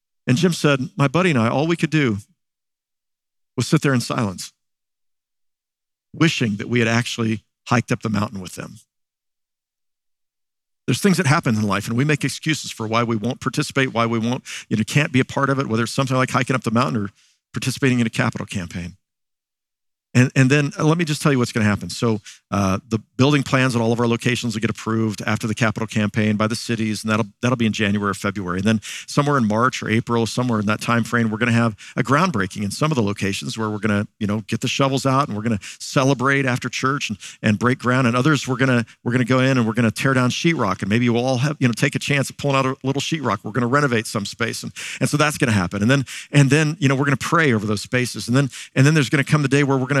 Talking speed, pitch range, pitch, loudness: 270 wpm, 110-135 Hz, 120 Hz, -20 LUFS